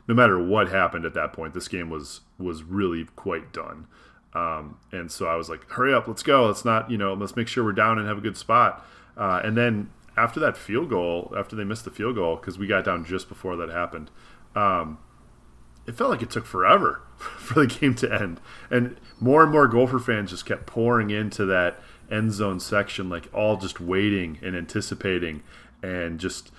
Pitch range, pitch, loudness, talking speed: 85-110 Hz, 100 Hz, -24 LUFS, 210 wpm